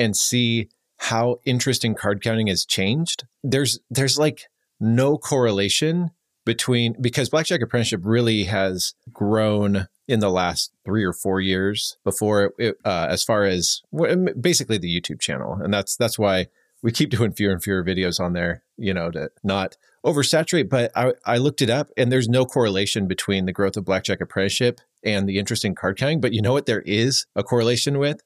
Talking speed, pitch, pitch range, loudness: 185 wpm, 115 Hz, 100-130 Hz, -21 LUFS